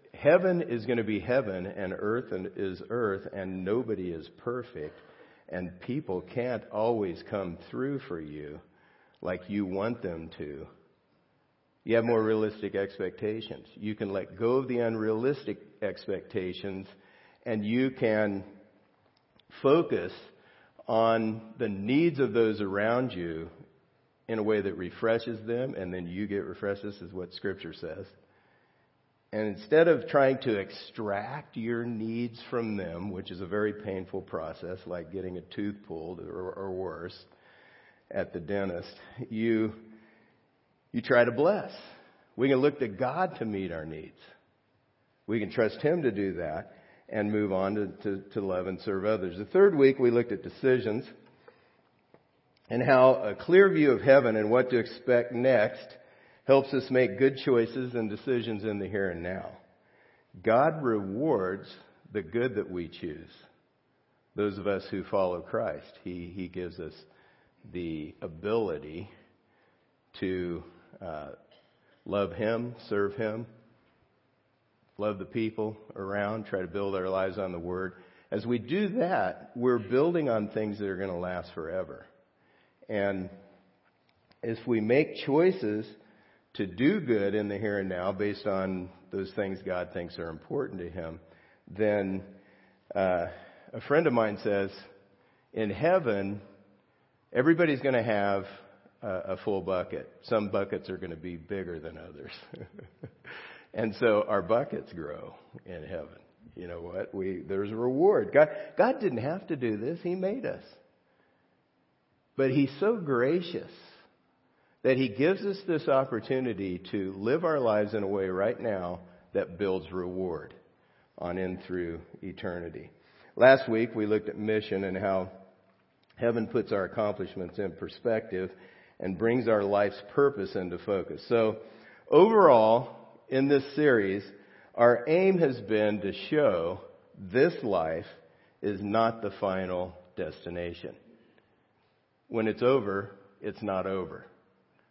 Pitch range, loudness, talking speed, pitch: 95-120 Hz, -29 LUFS, 145 wpm, 105 Hz